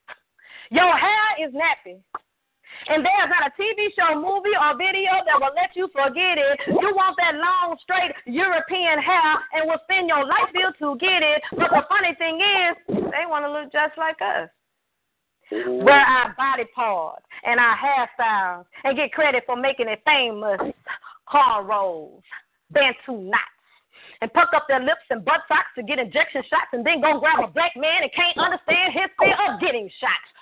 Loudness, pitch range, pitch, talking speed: -20 LUFS, 270-355 Hz, 310 Hz, 180 wpm